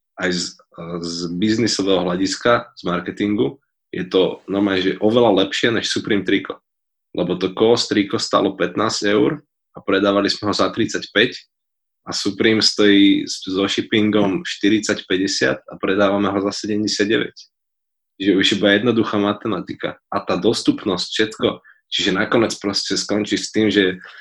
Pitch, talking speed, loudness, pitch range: 100 Hz, 140 wpm, -18 LUFS, 95-110 Hz